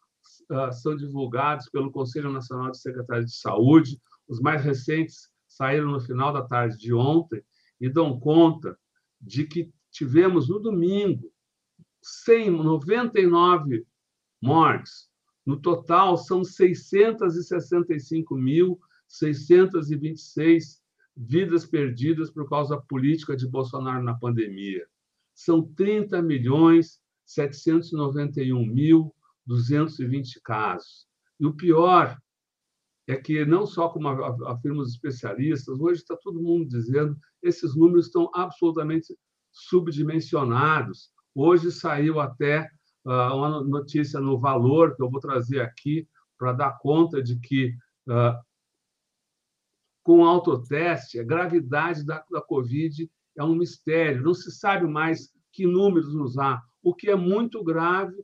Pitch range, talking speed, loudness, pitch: 135-170 Hz, 115 wpm, -23 LUFS, 155 Hz